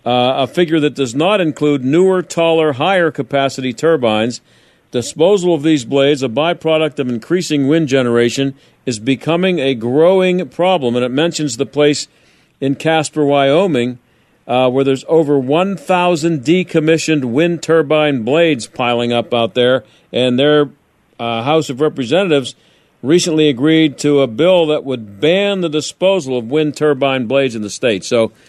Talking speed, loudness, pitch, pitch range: 150 wpm, -14 LUFS, 145 Hz, 130-160 Hz